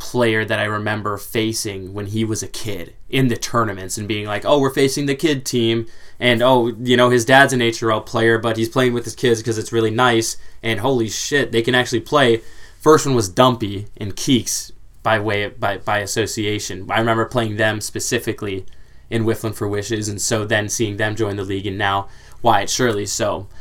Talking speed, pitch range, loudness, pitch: 210 wpm, 105-120 Hz, -18 LUFS, 110 Hz